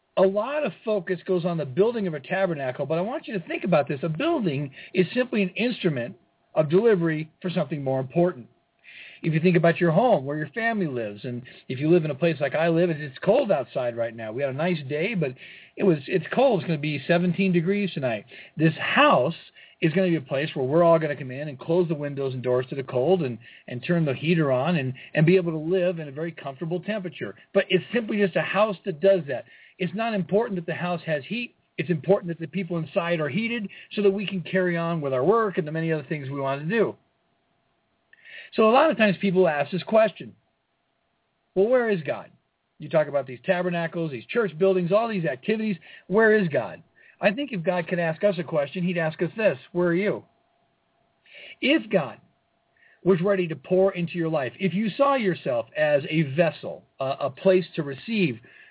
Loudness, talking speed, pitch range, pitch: -24 LUFS, 225 wpm, 155-195 Hz, 175 Hz